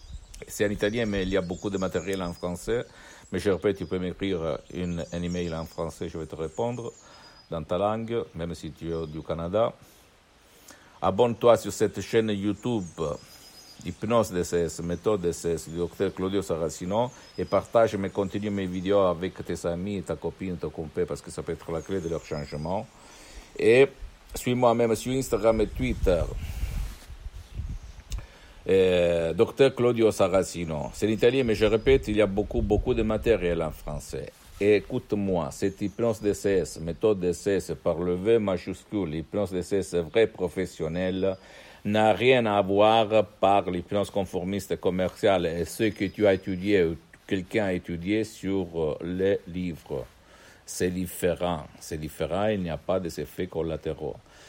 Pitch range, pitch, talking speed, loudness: 85-105 Hz, 95 Hz, 160 wpm, -27 LUFS